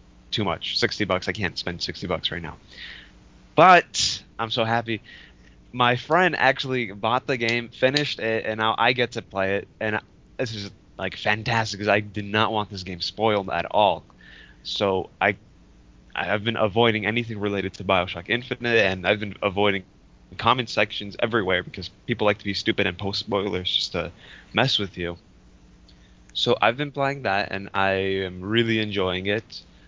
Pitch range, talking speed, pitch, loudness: 95-115 Hz, 175 wpm, 105 Hz, -23 LUFS